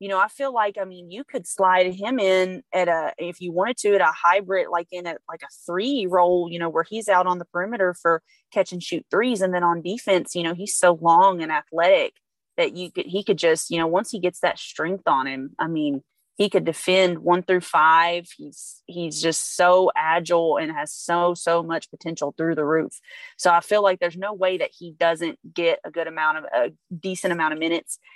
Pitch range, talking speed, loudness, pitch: 165-190 Hz, 230 wpm, -22 LUFS, 175 Hz